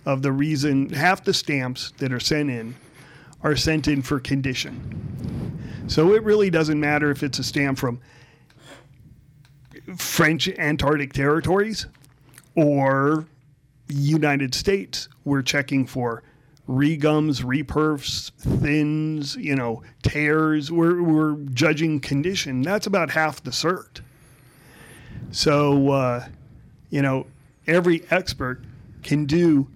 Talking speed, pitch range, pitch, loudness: 115 wpm, 135-155 Hz, 145 Hz, -22 LUFS